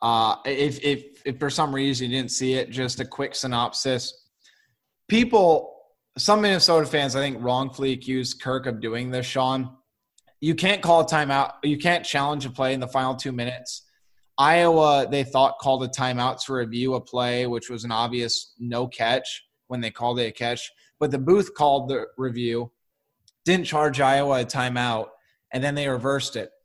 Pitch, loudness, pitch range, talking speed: 130 Hz, -23 LUFS, 125-145 Hz, 180 wpm